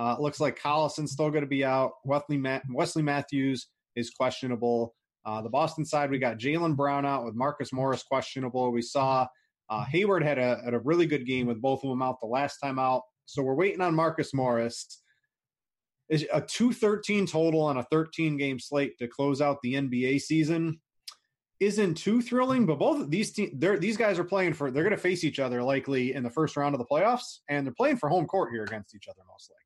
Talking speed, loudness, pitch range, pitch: 215 wpm, -28 LUFS, 130-160 Hz, 140 Hz